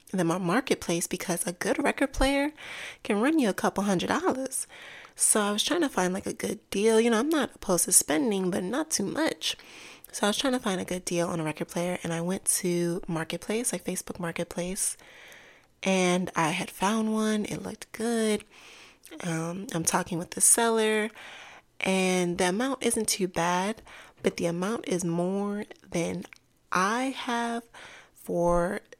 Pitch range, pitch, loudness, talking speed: 175-230 Hz, 190 Hz, -27 LUFS, 180 wpm